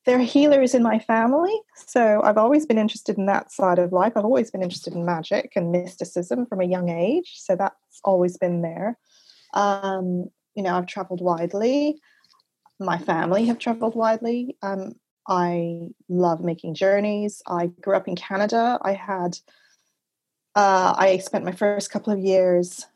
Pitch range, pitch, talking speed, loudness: 180-225 Hz, 195 Hz, 165 wpm, -22 LUFS